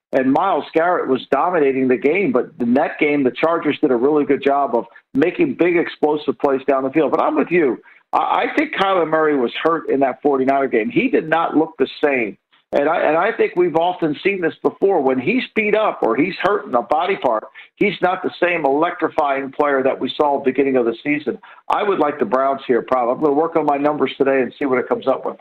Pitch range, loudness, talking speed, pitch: 135-165 Hz, -18 LUFS, 240 wpm, 145 Hz